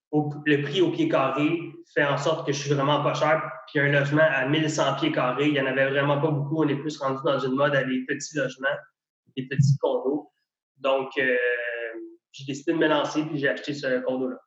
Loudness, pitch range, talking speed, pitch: -24 LUFS, 135-155 Hz, 225 wpm, 145 Hz